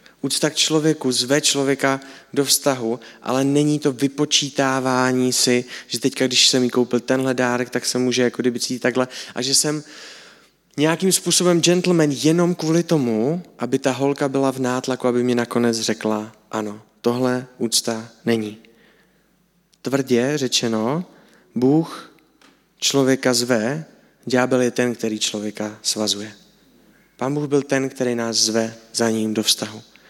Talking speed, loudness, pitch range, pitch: 145 wpm, -20 LUFS, 115-140 Hz, 125 Hz